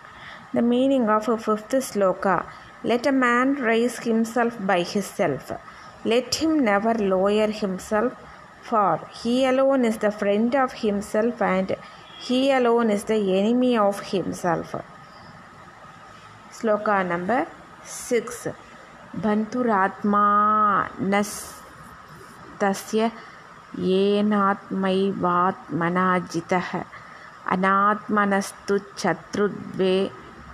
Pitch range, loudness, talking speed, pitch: 195-235 Hz, -23 LUFS, 85 wpm, 210 Hz